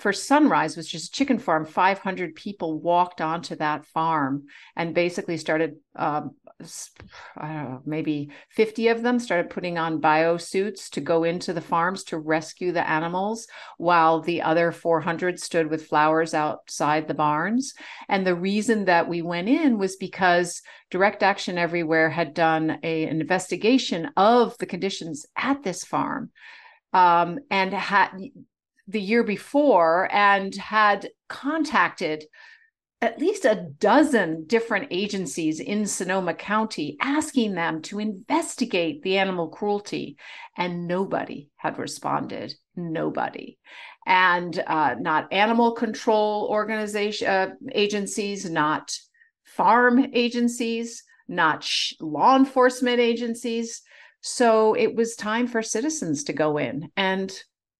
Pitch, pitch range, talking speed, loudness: 190 Hz, 165-230 Hz, 130 wpm, -23 LUFS